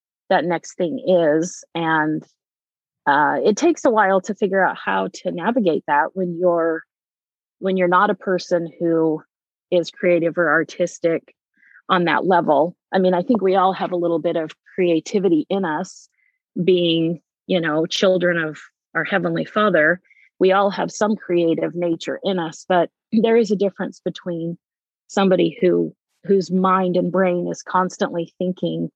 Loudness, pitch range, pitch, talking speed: -20 LUFS, 165-190 Hz, 180 Hz, 160 wpm